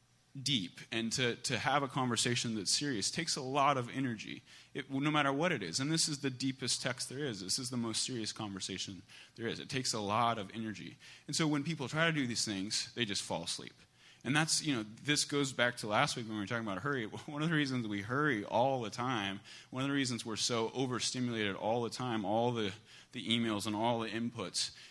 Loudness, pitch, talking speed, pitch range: -35 LUFS, 120 Hz, 240 wpm, 110-135 Hz